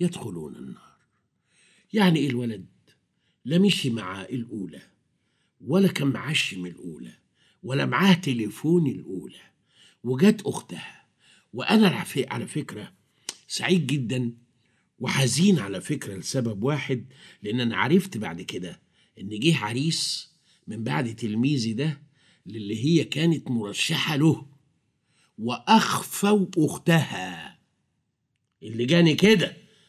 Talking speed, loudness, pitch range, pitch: 105 wpm, -24 LUFS, 120-175 Hz, 145 Hz